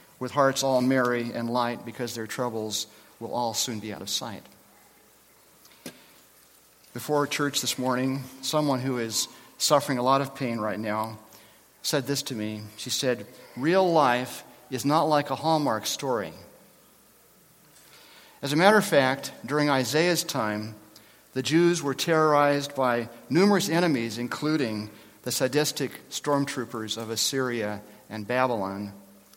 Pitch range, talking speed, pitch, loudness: 115-145 Hz, 135 wpm, 125 Hz, -26 LUFS